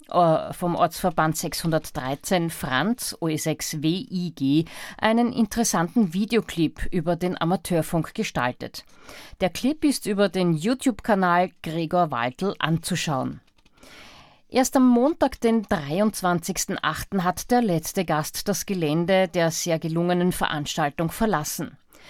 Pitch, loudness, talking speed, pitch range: 180 Hz, -24 LUFS, 105 wpm, 160-210 Hz